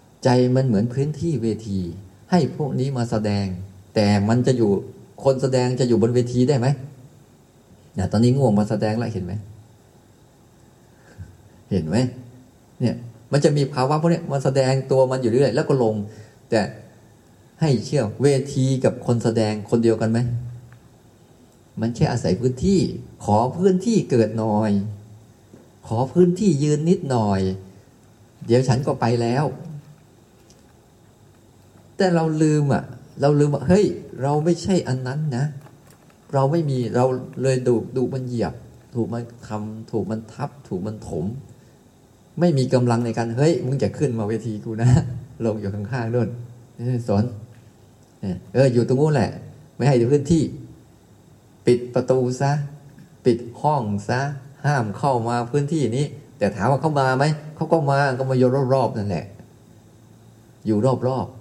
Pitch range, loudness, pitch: 115-140 Hz, -21 LUFS, 125 Hz